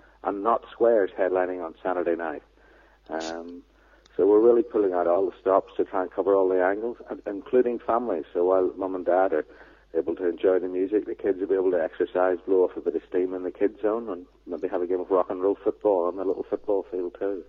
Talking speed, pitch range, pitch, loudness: 240 wpm, 90-120 Hz, 95 Hz, -25 LUFS